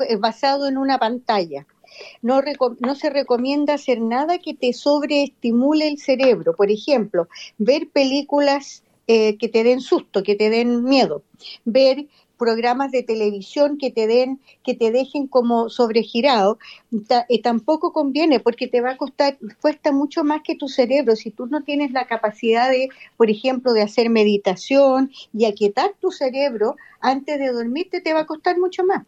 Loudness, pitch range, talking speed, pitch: -19 LUFS, 230-285 Hz, 165 wpm, 255 Hz